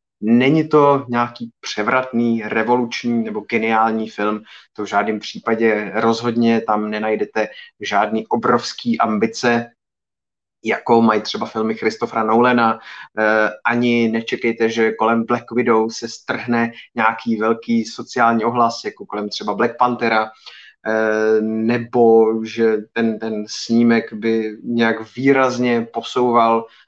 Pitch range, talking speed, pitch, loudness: 110-120 Hz, 110 wpm, 115 Hz, -18 LUFS